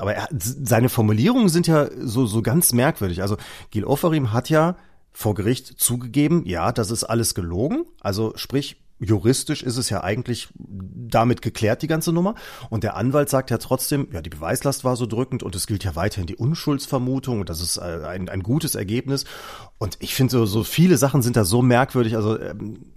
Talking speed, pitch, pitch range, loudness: 195 wpm, 120 Hz, 105-140 Hz, -21 LUFS